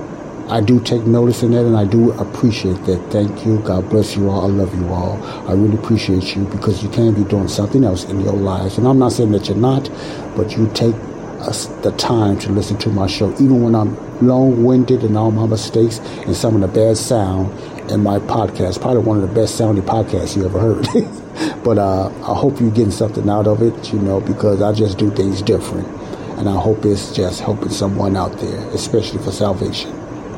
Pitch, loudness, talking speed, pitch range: 105 Hz, -16 LUFS, 215 wpm, 100-115 Hz